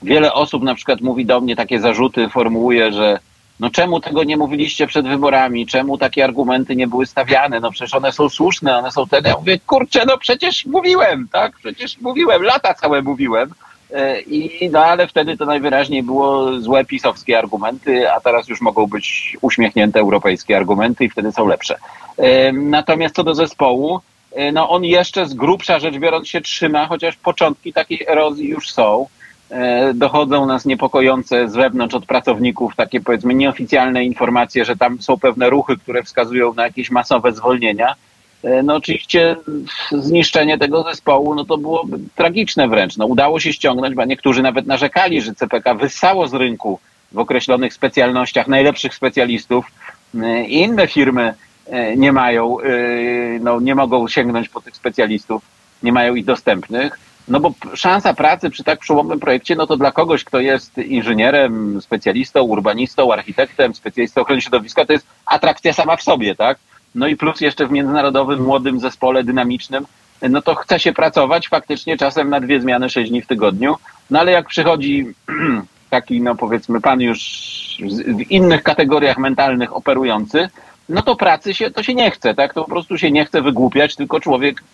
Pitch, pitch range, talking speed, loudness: 135 Hz, 125-160 Hz, 165 wpm, -15 LUFS